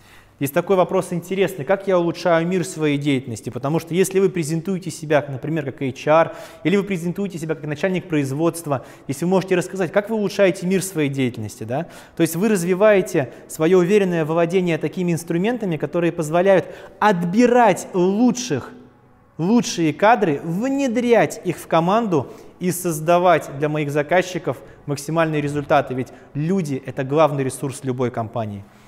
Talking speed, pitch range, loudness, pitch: 145 wpm, 145-185 Hz, -20 LUFS, 165 Hz